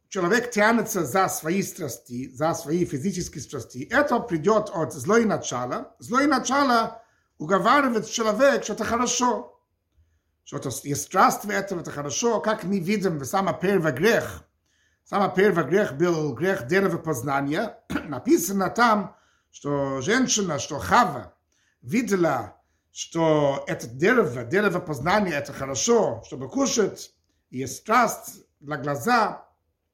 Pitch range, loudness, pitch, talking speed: 145-215 Hz, -23 LUFS, 180 Hz, 110 wpm